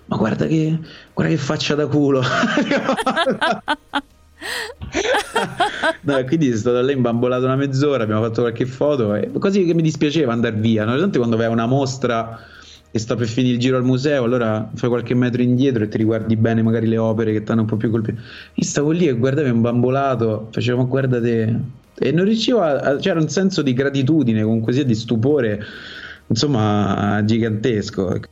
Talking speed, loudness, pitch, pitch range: 180 wpm, -19 LUFS, 125 Hz, 115-145 Hz